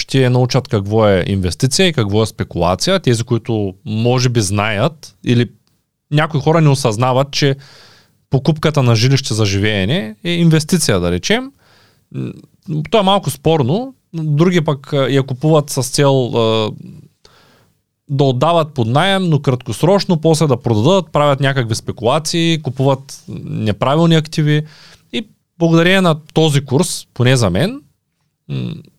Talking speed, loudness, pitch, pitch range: 130 wpm, -15 LUFS, 140 Hz, 120-160 Hz